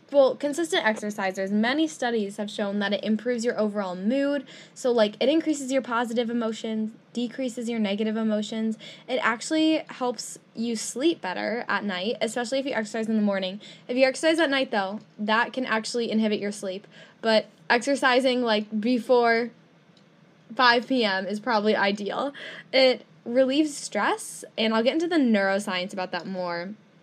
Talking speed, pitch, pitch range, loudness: 160 wpm, 225 Hz, 205-255 Hz, -25 LUFS